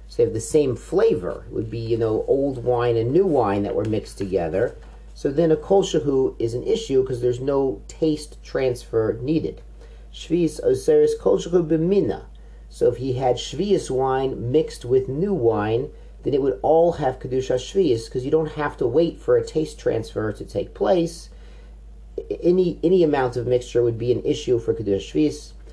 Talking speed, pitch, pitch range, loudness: 180 wpm, 130 Hz, 115-165 Hz, -22 LUFS